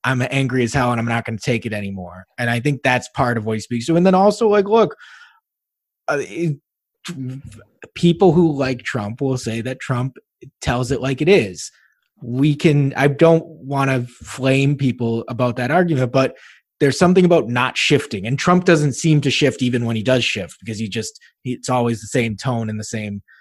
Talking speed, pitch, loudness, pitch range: 205 wpm, 130 Hz, -18 LUFS, 115-145 Hz